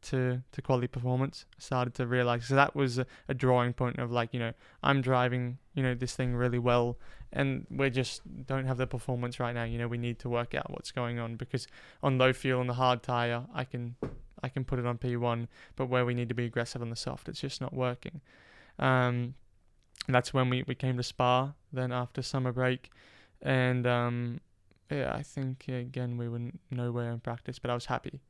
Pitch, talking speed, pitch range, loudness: 125 Hz, 220 wpm, 120-130 Hz, -32 LUFS